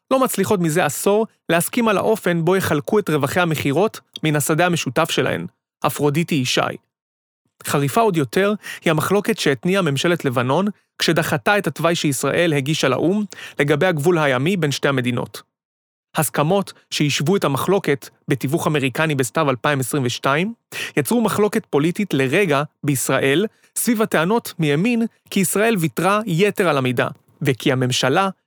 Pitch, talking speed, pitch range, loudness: 165 Hz, 130 wpm, 145-195 Hz, -19 LUFS